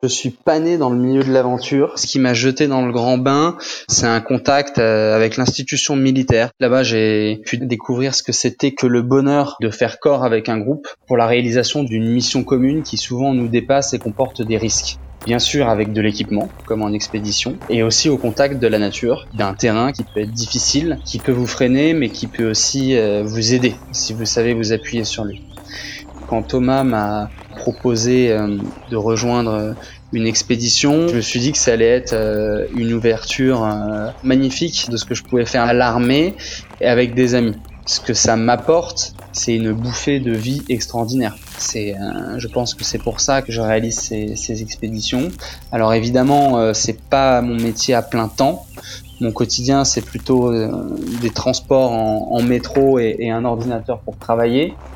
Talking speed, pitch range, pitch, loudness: 190 wpm, 110-130 Hz, 120 Hz, -17 LUFS